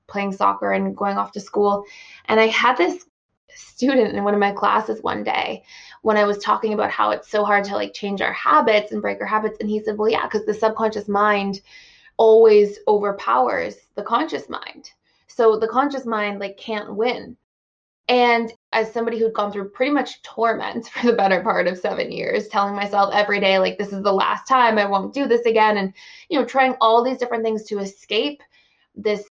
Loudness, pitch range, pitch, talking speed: -20 LUFS, 200-235 Hz, 215 Hz, 205 wpm